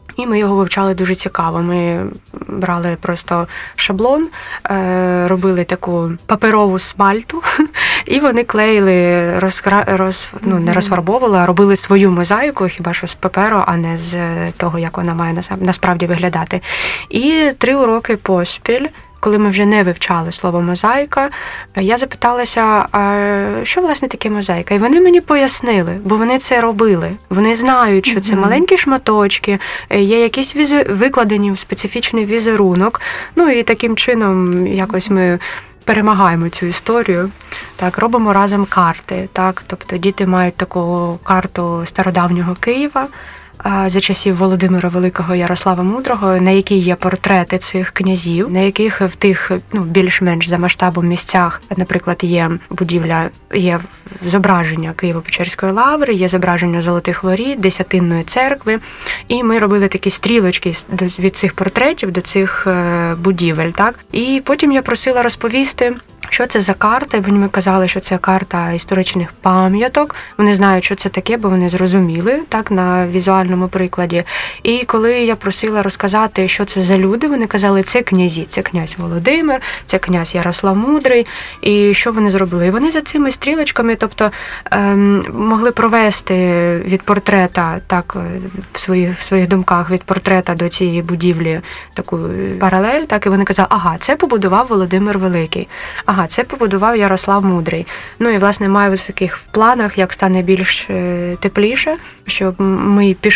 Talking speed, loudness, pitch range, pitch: 145 wpm, -13 LUFS, 180-220 Hz, 195 Hz